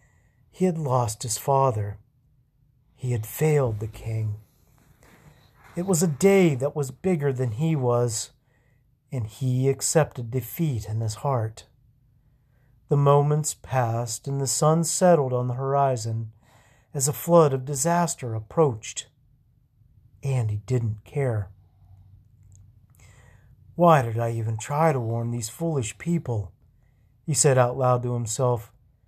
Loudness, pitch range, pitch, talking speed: -24 LUFS, 115-140 Hz, 125 Hz, 130 wpm